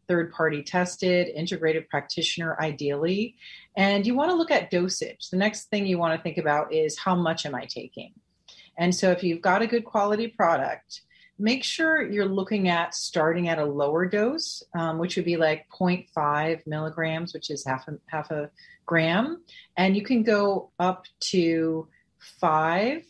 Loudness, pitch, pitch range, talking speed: -25 LUFS, 175 Hz, 160-200 Hz, 175 wpm